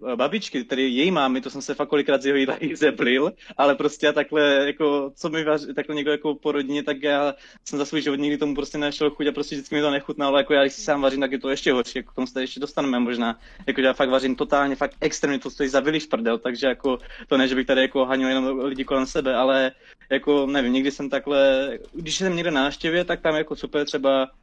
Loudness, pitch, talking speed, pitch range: -23 LUFS, 140 Hz, 255 wpm, 135-150 Hz